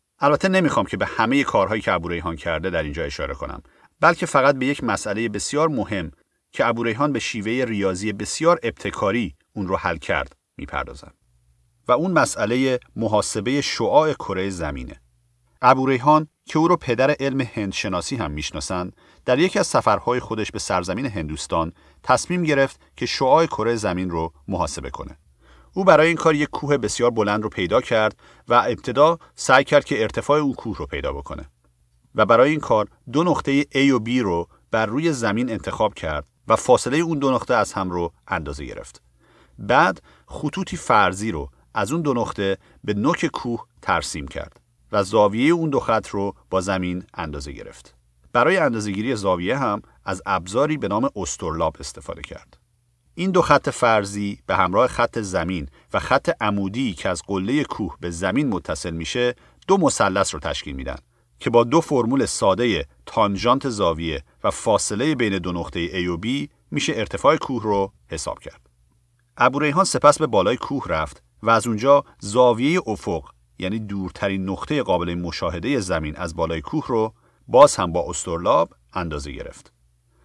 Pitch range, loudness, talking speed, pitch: 85-135 Hz, -21 LUFS, 165 wpm, 110 Hz